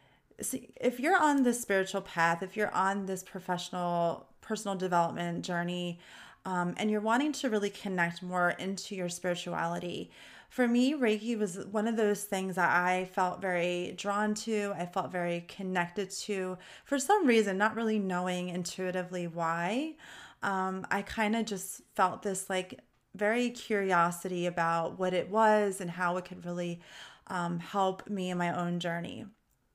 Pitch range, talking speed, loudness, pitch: 175-210 Hz, 160 wpm, -32 LUFS, 190 Hz